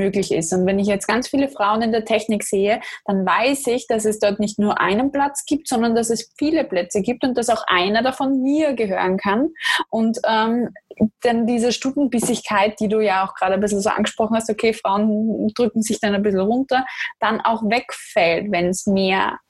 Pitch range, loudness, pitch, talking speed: 205-245 Hz, -19 LUFS, 220 Hz, 205 wpm